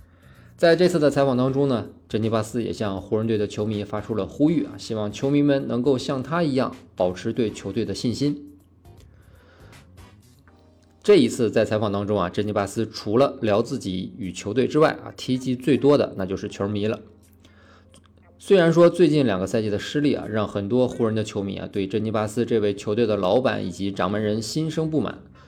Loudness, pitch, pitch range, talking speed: -23 LUFS, 105 Hz, 95-130 Hz, 290 characters per minute